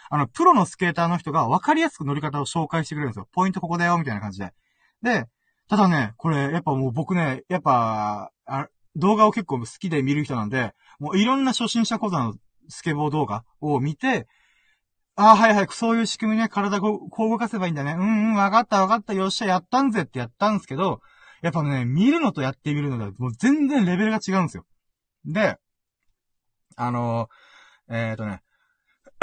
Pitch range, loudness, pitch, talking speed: 135-215 Hz, -22 LUFS, 175 Hz, 395 characters per minute